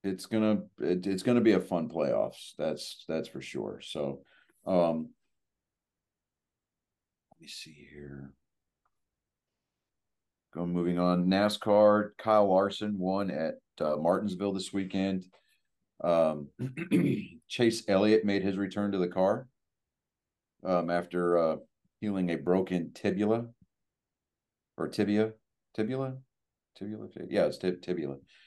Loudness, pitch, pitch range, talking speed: -30 LUFS, 95 Hz, 90-105 Hz, 120 wpm